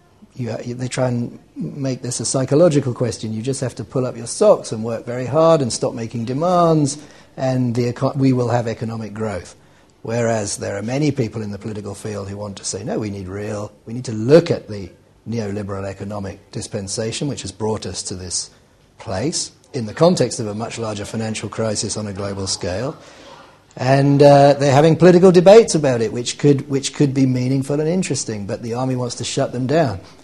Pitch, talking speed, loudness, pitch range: 120 Hz, 200 wpm, -18 LUFS, 105-135 Hz